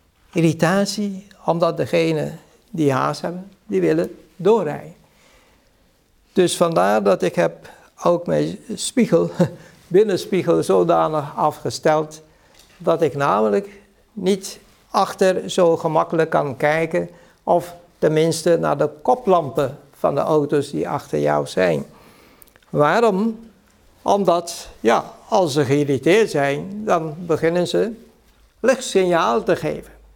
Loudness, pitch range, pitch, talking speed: -19 LUFS, 155-195 Hz, 170 Hz, 105 wpm